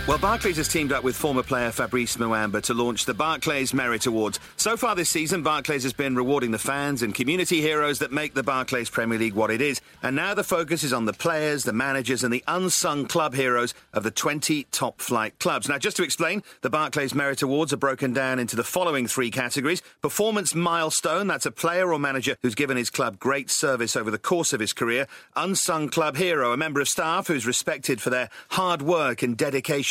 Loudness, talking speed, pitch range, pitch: -24 LUFS, 220 wpm, 125-160 Hz, 140 Hz